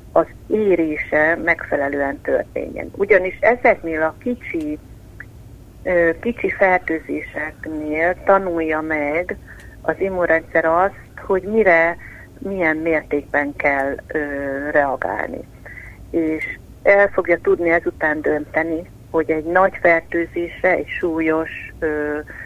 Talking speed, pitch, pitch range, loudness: 90 wpm, 160 Hz, 150-180 Hz, -19 LUFS